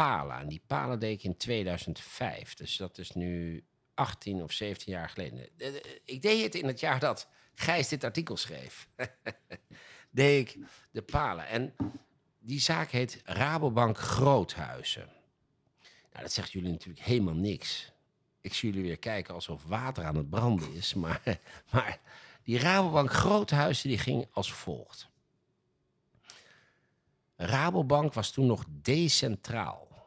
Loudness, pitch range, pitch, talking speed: -31 LUFS, 90-135 Hz, 115 Hz, 140 wpm